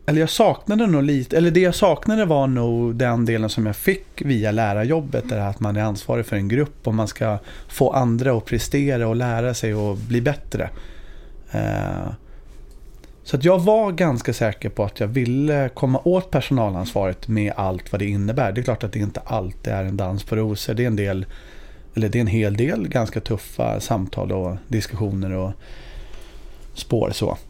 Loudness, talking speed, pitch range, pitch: -21 LUFS, 190 wpm, 105-135 Hz, 115 Hz